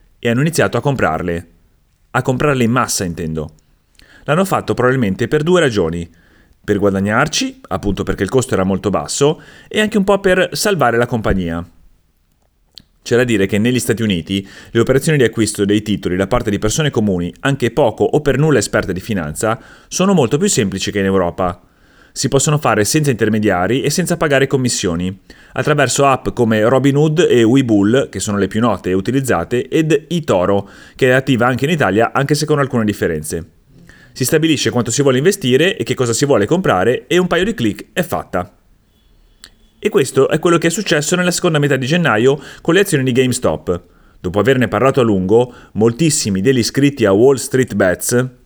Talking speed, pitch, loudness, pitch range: 185 wpm, 120 Hz, -15 LUFS, 100-140 Hz